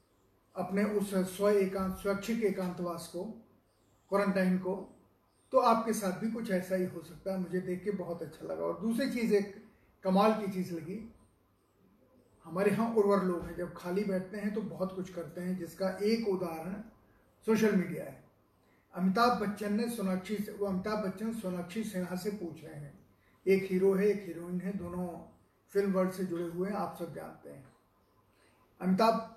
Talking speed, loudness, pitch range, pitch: 170 wpm, -33 LUFS, 175-205 Hz, 190 Hz